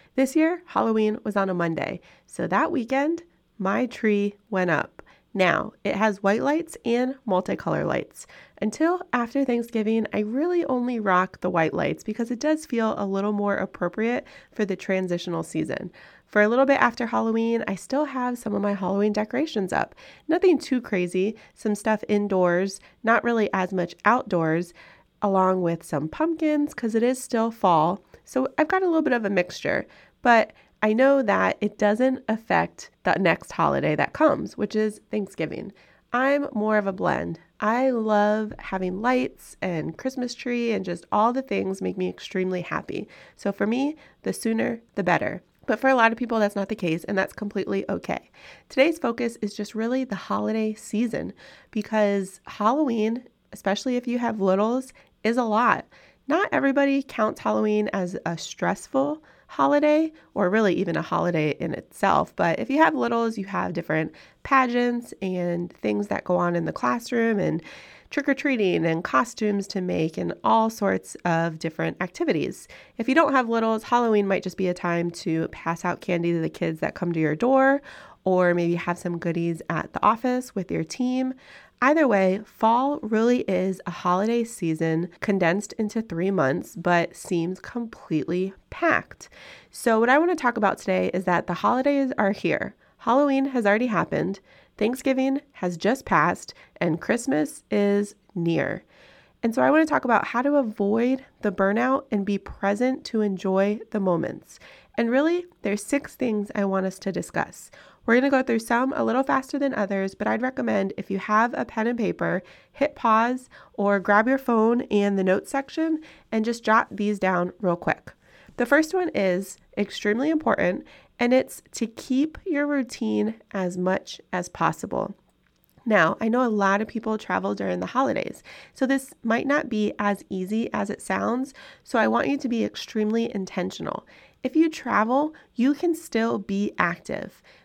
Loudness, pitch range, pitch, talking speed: -24 LUFS, 190-255 Hz, 215 Hz, 175 wpm